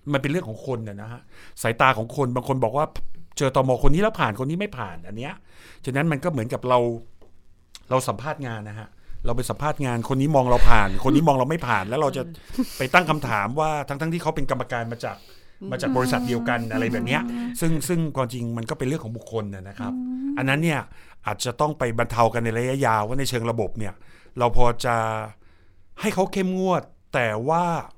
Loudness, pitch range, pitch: -24 LUFS, 115-150 Hz, 125 Hz